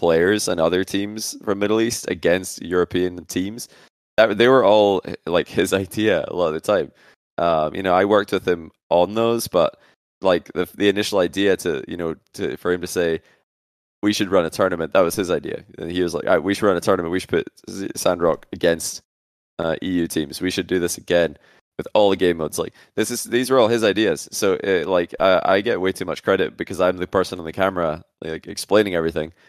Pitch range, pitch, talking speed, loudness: 85-100 Hz, 90 Hz, 225 wpm, -20 LUFS